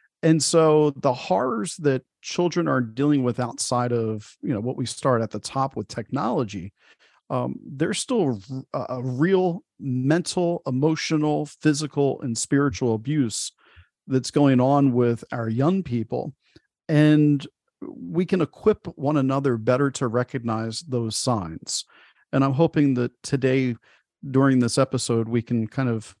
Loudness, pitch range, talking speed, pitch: -23 LUFS, 120-150 Hz, 140 wpm, 135 Hz